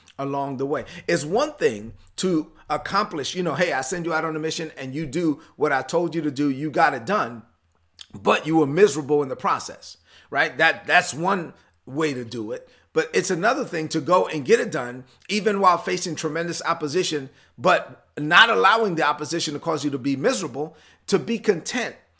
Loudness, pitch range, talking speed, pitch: -22 LUFS, 145-180 Hz, 205 wpm, 160 Hz